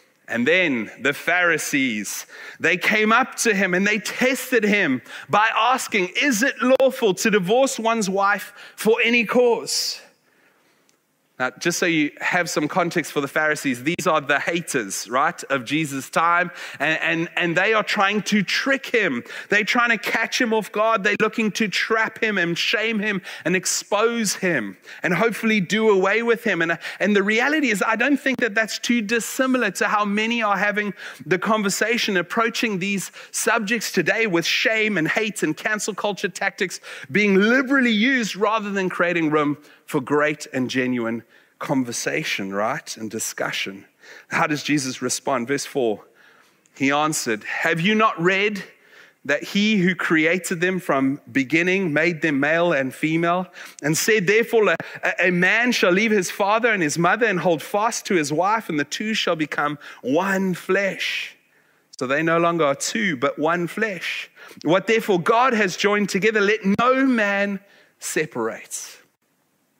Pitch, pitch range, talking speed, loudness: 200 Hz, 165-225 Hz, 165 wpm, -20 LUFS